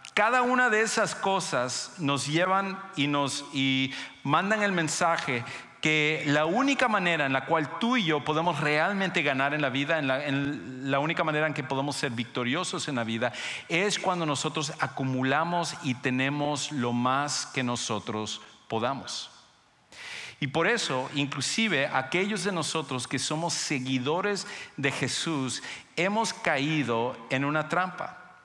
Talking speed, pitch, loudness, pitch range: 150 wpm, 150 Hz, -27 LUFS, 135-175 Hz